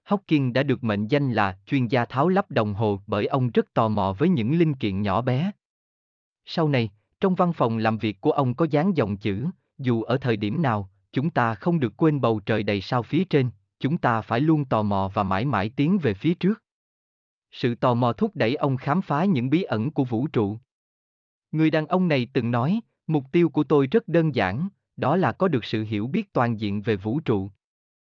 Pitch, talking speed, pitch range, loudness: 125 Hz, 225 wpm, 105-160 Hz, -24 LUFS